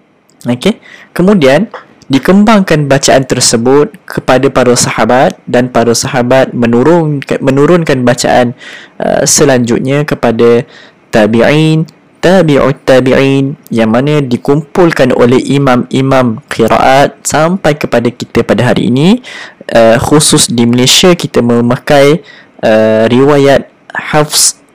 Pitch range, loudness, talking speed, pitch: 120-150 Hz, -8 LUFS, 100 wpm, 135 Hz